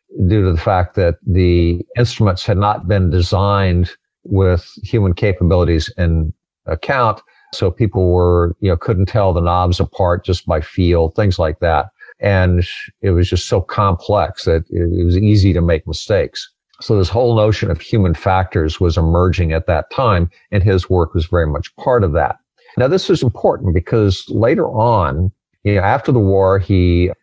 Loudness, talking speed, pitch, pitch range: -15 LUFS, 175 wpm, 95 Hz, 85-105 Hz